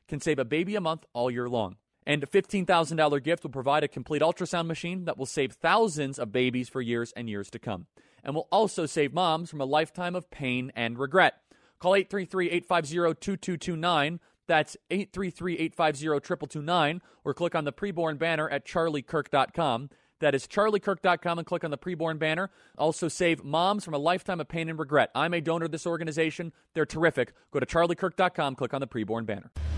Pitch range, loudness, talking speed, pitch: 140-175 Hz, -28 LUFS, 180 wpm, 160 Hz